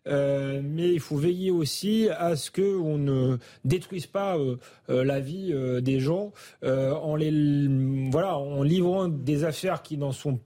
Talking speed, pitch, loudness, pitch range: 185 wpm, 150 Hz, -27 LUFS, 135-175 Hz